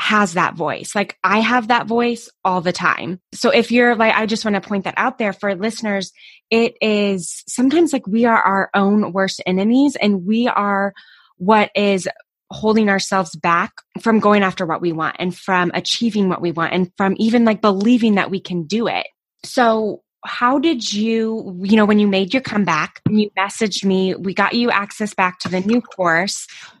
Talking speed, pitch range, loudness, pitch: 200 wpm, 190-225 Hz, -17 LUFS, 205 Hz